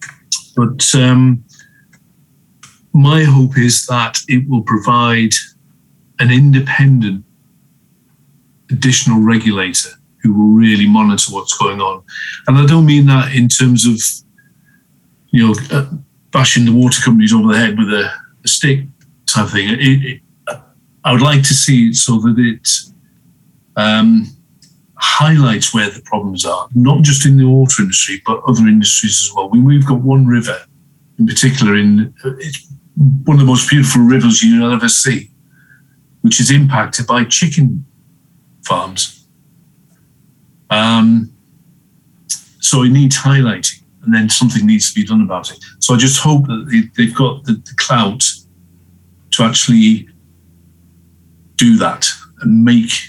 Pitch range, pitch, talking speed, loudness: 115-150 Hz, 130 Hz, 145 wpm, -11 LUFS